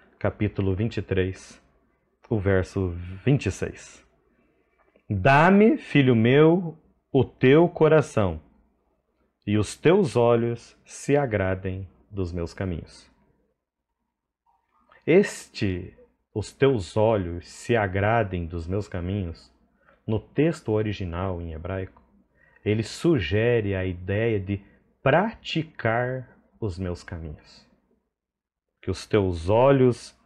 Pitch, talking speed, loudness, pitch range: 105 Hz, 95 wpm, -24 LUFS, 95-125 Hz